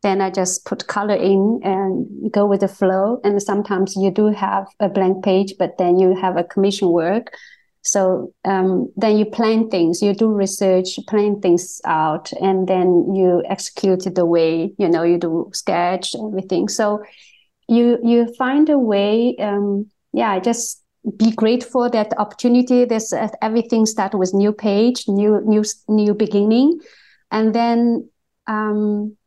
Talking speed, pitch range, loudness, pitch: 160 wpm, 190-220 Hz, -18 LUFS, 205 Hz